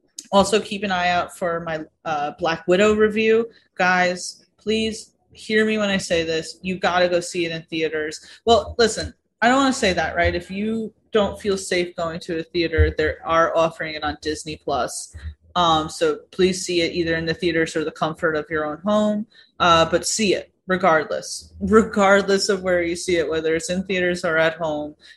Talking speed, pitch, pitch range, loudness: 205 wpm, 180 Hz, 165-205 Hz, -21 LUFS